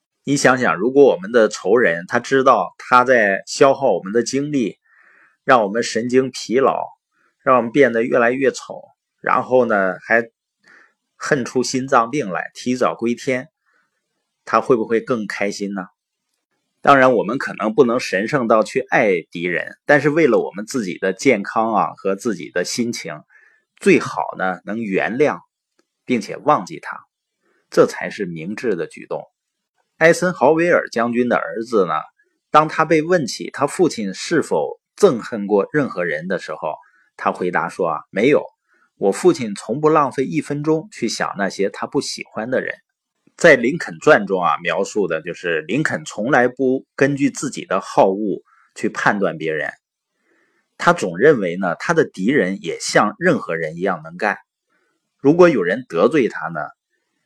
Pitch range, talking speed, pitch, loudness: 120-170 Hz, 235 characters per minute, 135 Hz, -18 LUFS